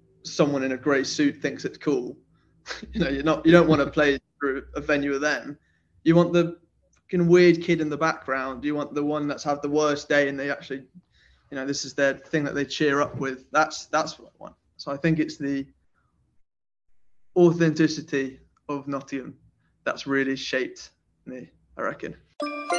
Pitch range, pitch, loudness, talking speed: 135-160 Hz, 145 Hz, -24 LUFS, 190 wpm